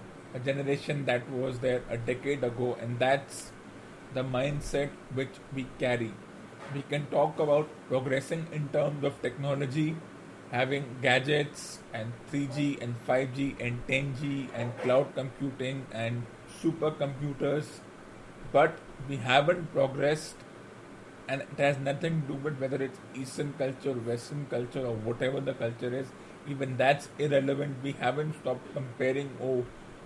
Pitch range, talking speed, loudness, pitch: 125-145 Hz, 140 wpm, -31 LUFS, 135 Hz